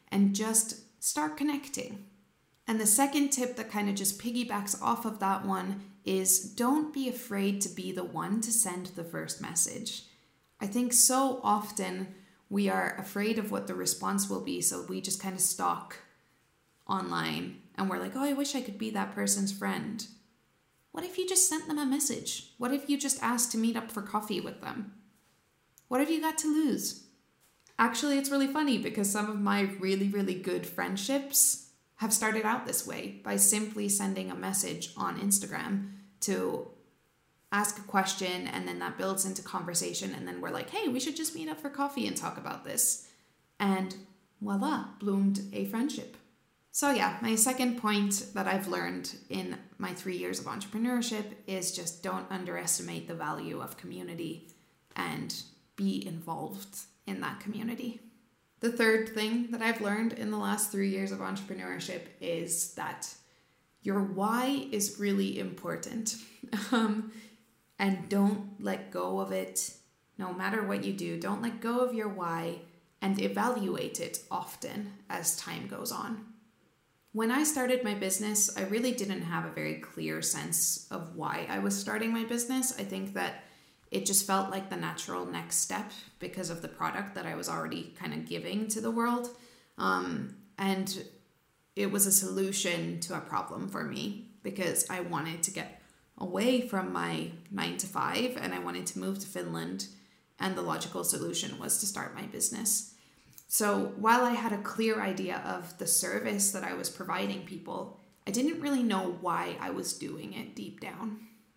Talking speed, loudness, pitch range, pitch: 175 wpm, -31 LUFS, 190-230 Hz, 205 Hz